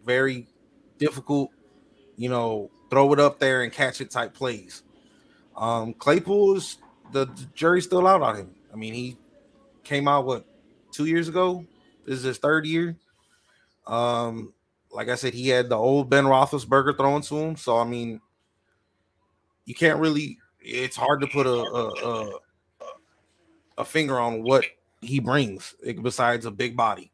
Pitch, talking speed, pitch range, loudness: 135 Hz, 160 wpm, 120-150 Hz, -24 LUFS